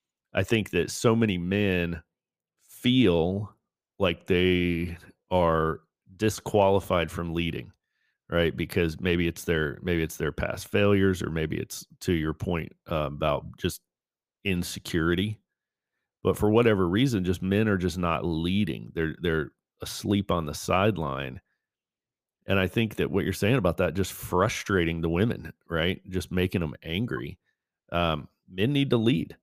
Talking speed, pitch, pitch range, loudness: 145 wpm, 90 Hz, 85-100 Hz, -27 LUFS